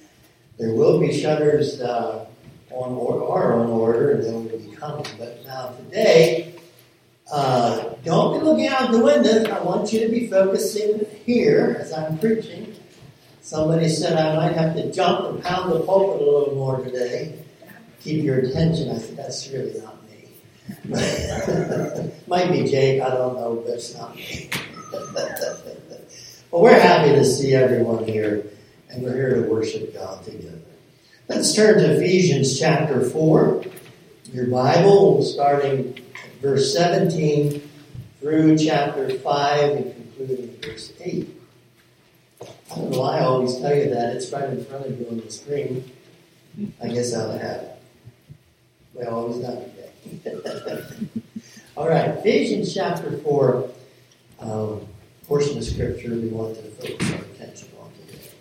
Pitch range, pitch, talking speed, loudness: 125-175 Hz, 145 Hz, 150 wpm, -20 LUFS